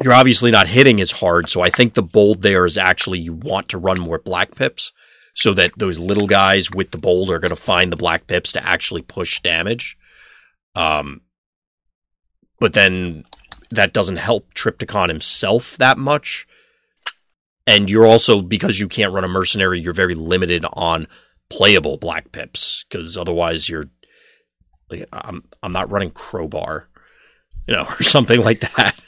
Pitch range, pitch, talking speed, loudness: 85-110 Hz, 95 Hz, 165 wpm, -15 LUFS